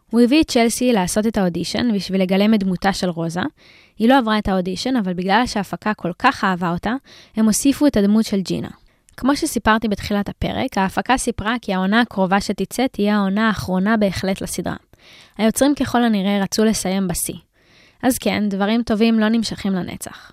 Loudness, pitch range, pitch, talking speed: -19 LUFS, 195-235 Hz, 210 Hz, 175 wpm